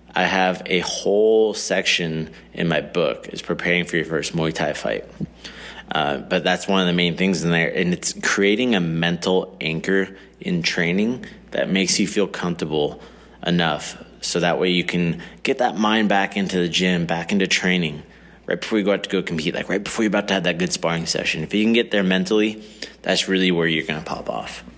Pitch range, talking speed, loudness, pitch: 85-100 Hz, 215 wpm, -21 LUFS, 90 Hz